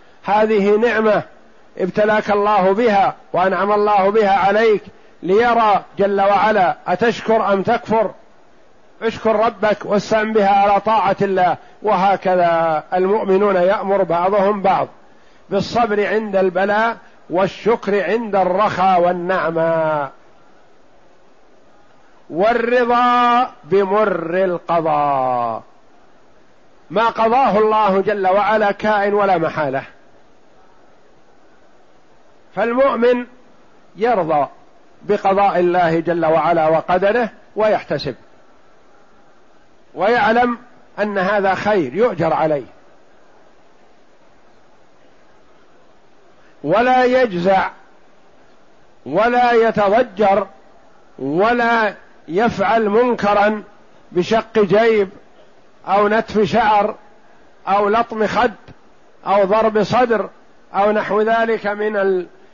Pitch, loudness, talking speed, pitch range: 205 Hz, -16 LUFS, 80 wpm, 190-225 Hz